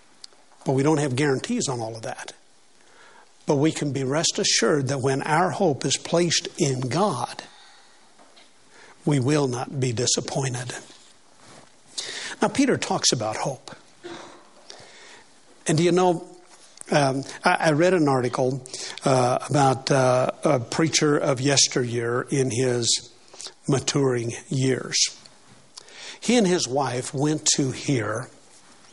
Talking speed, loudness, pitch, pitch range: 125 wpm, -23 LUFS, 140 Hz, 130-170 Hz